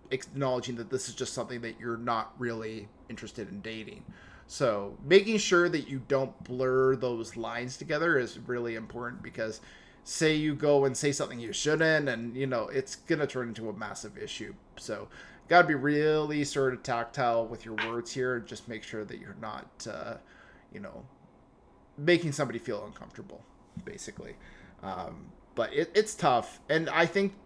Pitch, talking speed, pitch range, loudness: 130 Hz, 175 wpm, 115-150 Hz, -30 LUFS